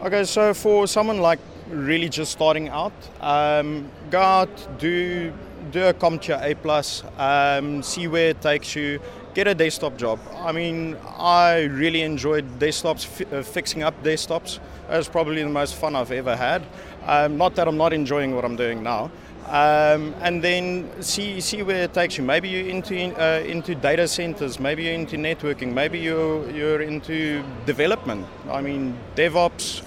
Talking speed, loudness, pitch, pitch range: 170 wpm, -22 LUFS, 160 Hz, 145-175 Hz